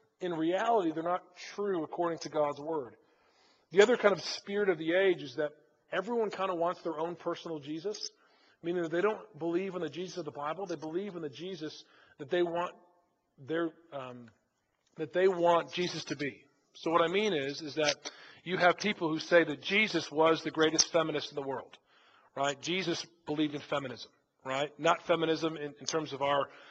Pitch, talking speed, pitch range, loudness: 165 Hz, 200 wpm, 150-180 Hz, -32 LUFS